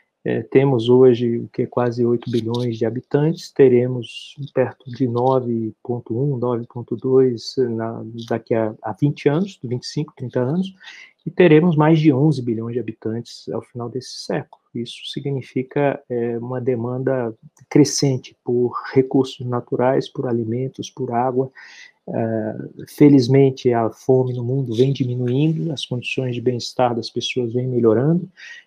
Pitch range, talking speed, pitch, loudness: 120-135 Hz, 135 wpm, 125 Hz, -20 LUFS